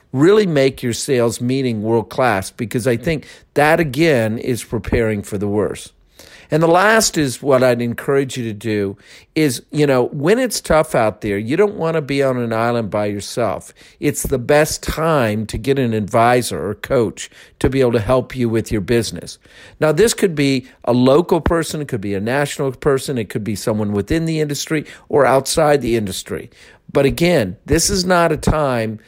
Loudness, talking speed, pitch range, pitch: -17 LUFS, 195 wpm, 115-155 Hz, 130 Hz